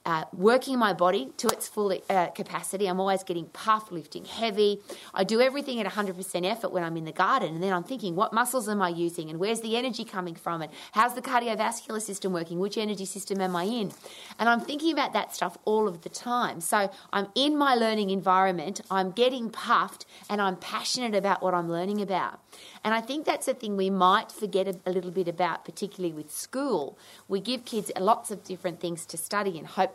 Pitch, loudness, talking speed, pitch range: 195 Hz, -28 LUFS, 215 wpm, 180-220 Hz